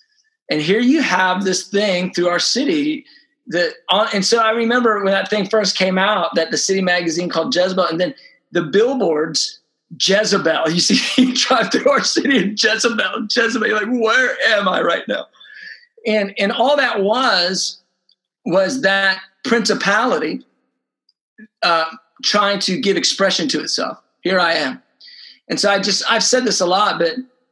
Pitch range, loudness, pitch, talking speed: 185-245 Hz, -16 LUFS, 205 Hz, 165 wpm